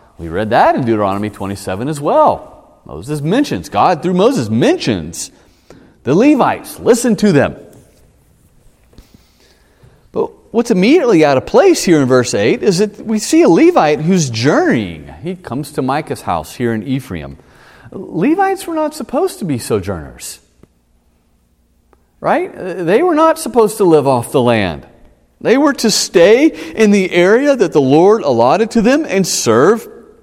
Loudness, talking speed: -13 LUFS, 155 wpm